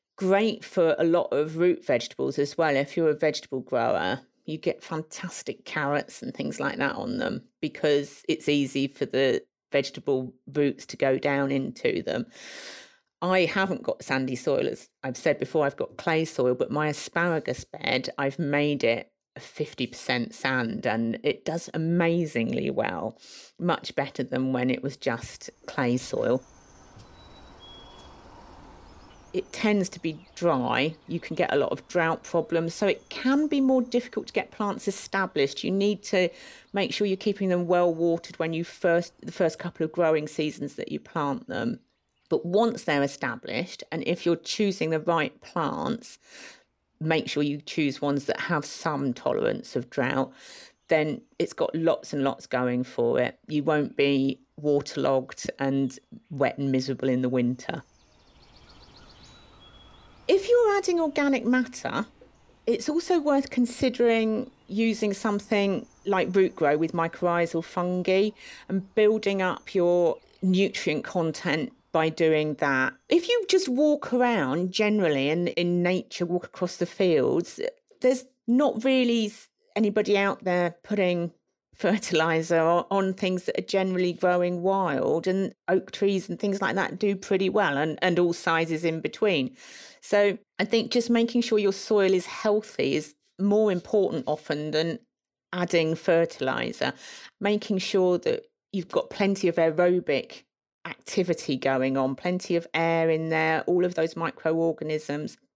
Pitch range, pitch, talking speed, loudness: 155-205 Hz, 175 Hz, 155 wpm, -26 LUFS